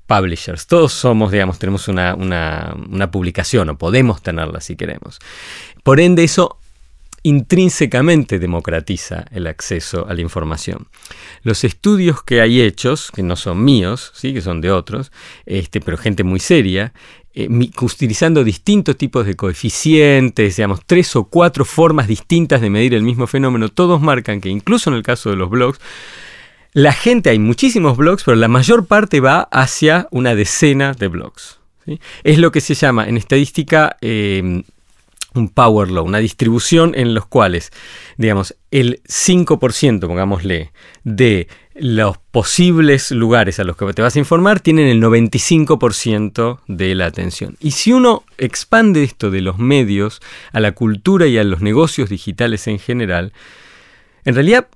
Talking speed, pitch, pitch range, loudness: 155 wpm, 115 Hz, 95-145 Hz, -14 LUFS